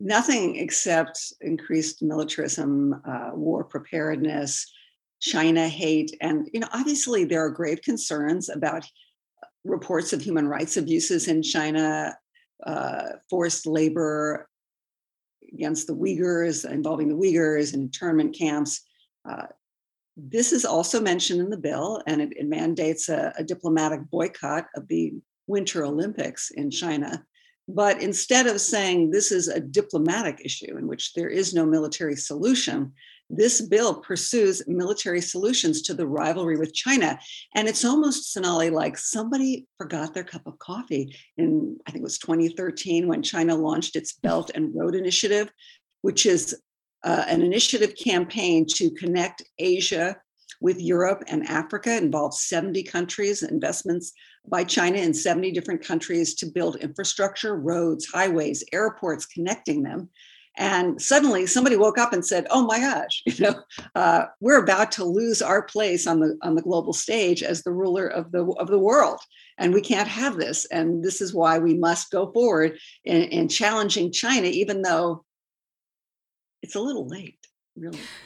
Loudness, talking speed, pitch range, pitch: -24 LUFS, 150 wpm, 165-260 Hz, 185 Hz